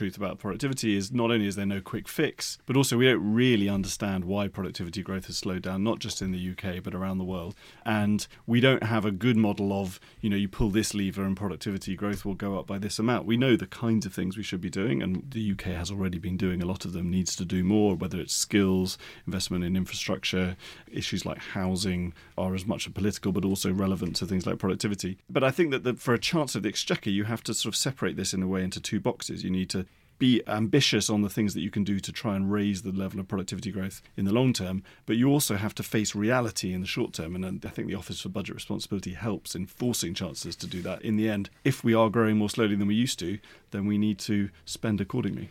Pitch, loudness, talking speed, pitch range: 100 Hz, -28 LUFS, 255 wpm, 95-110 Hz